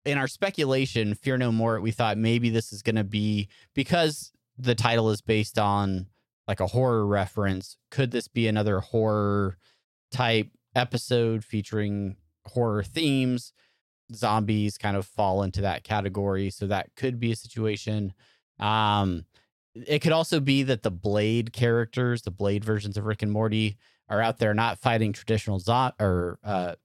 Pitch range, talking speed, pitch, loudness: 100-120 Hz, 160 wpm, 110 Hz, -26 LUFS